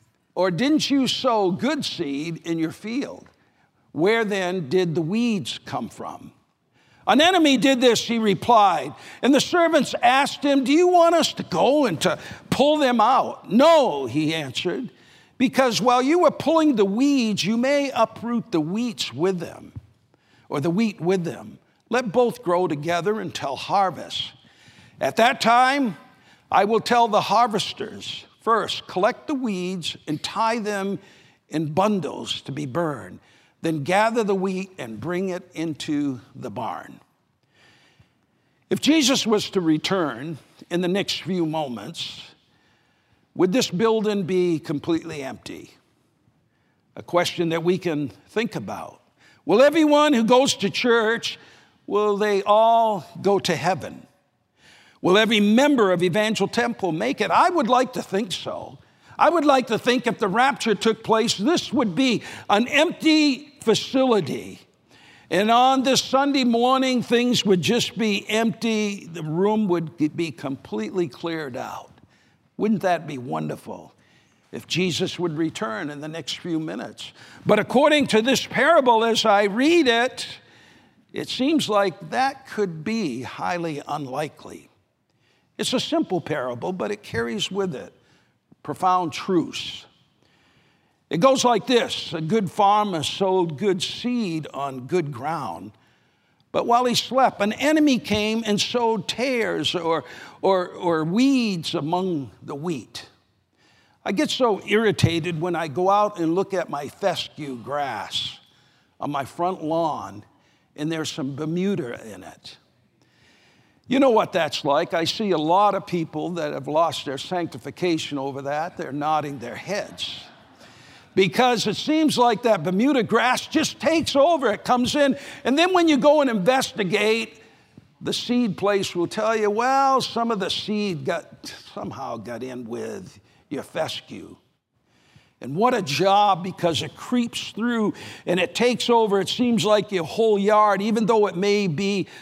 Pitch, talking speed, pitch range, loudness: 200 Hz, 150 wpm, 165-240 Hz, -22 LUFS